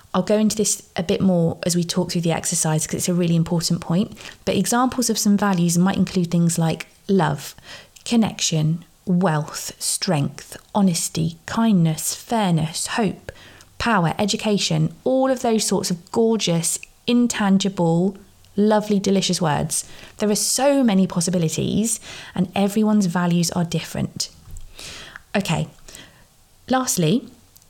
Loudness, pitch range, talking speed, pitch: -20 LUFS, 170-210 Hz, 130 wpm, 190 Hz